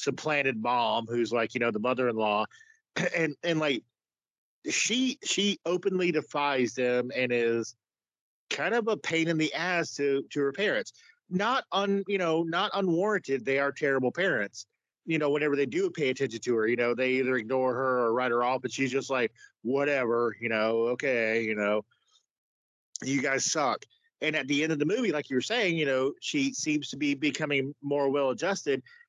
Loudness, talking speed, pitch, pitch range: -28 LUFS, 190 wpm, 140 Hz, 125-175 Hz